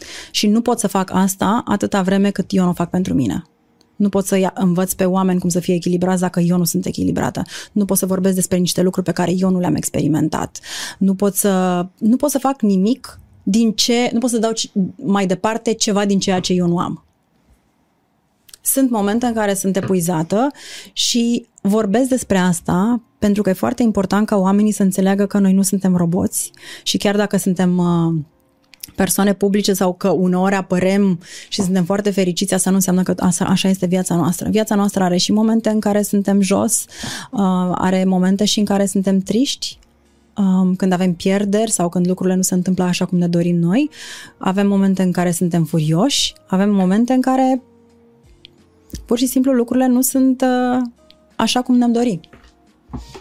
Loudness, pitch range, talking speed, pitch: -17 LUFS, 185-215 Hz, 185 wpm, 195 Hz